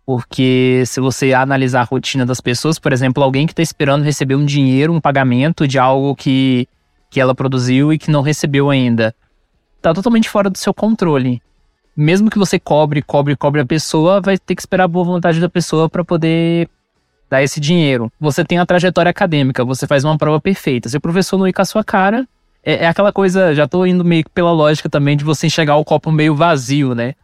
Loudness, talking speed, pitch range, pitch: -14 LUFS, 215 wpm, 135-175 Hz, 150 Hz